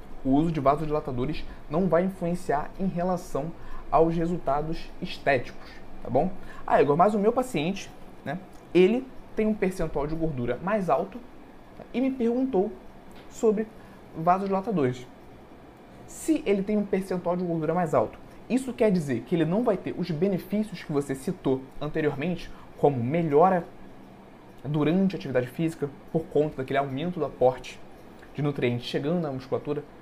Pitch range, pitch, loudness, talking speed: 145-190 Hz, 165 Hz, -27 LUFS, 150 wpm